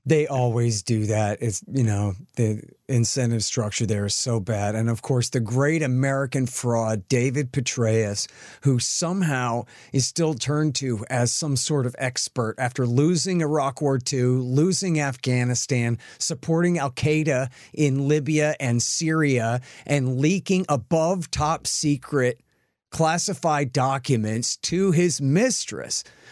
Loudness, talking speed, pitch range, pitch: -23 LUFS, 130 wpm, 120-150 Hz, 130 Hz